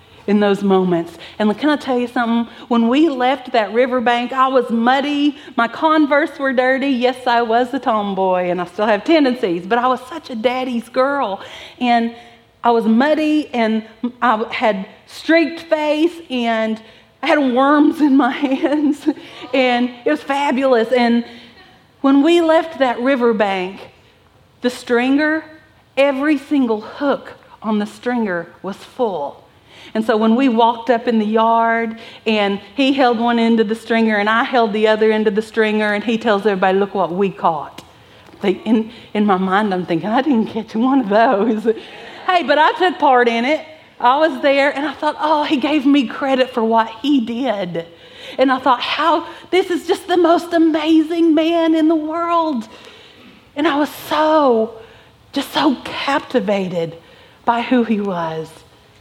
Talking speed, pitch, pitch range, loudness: 170 wpm, 245 Hz, 220-290 Hz, -16 LUFS